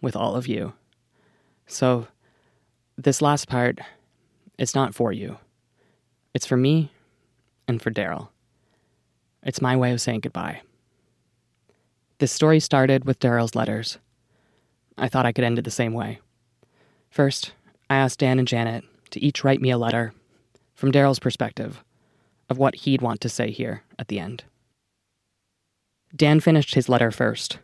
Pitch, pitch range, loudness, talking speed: 125 Hz, 115-135 Hz, -23 LUFS, 150 wpm